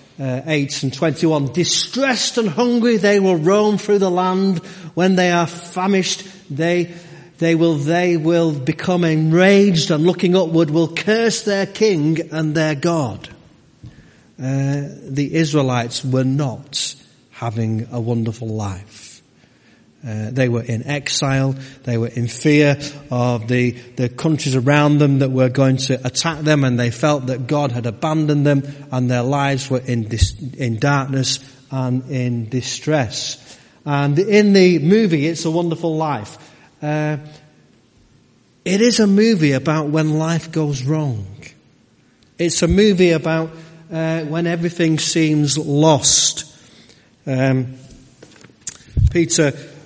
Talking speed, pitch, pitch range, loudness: 135 wpm, 150 Hz, 130-170 Hz, -17 LUFS